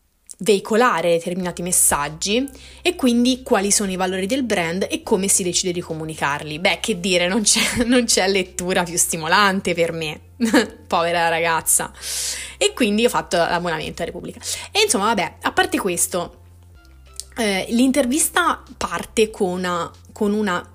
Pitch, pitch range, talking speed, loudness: 190 Hz, 170-235 Hz, 145 wpm, -19 LUFS